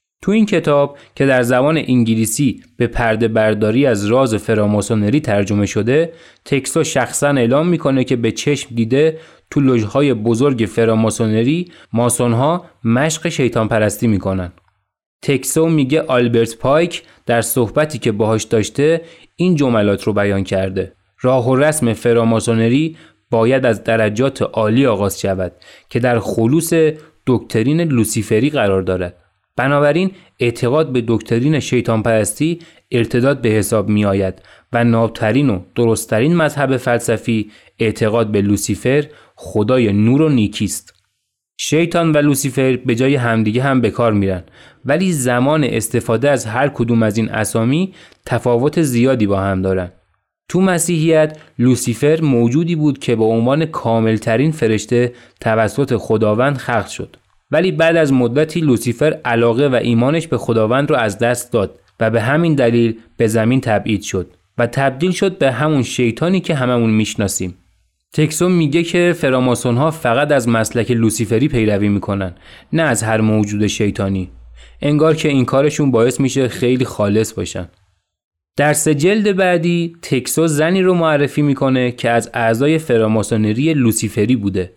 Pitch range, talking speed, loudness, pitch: 110-145 Hz, 140 wpm, -15 LUFS, 120 Hz